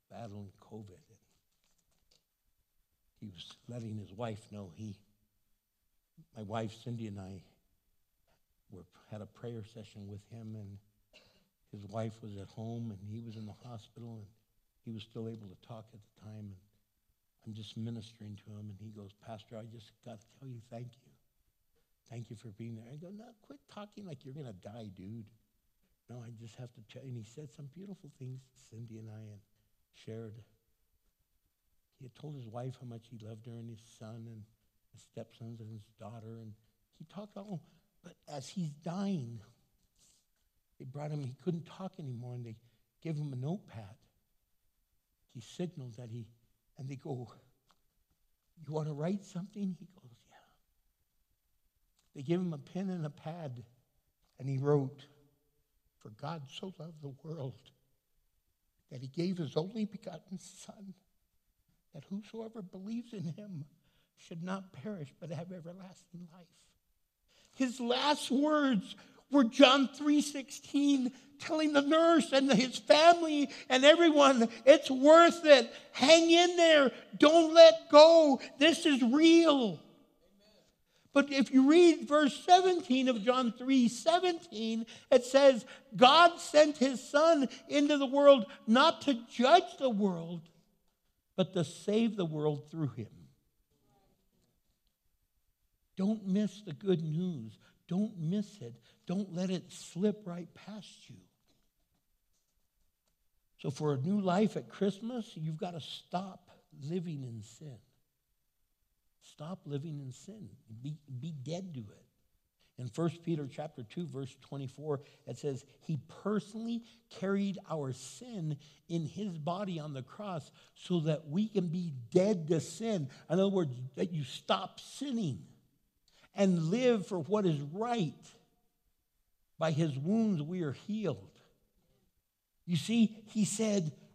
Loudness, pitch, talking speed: -30 LUFS, 155 Hz, 150 wpm